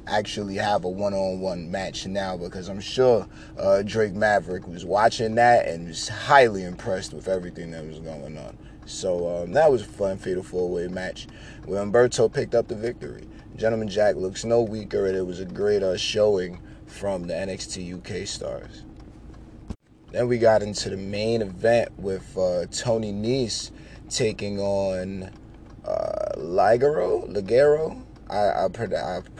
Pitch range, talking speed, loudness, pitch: 95-110 Hz, 165 wpm, -24 LUFS, 100 Hz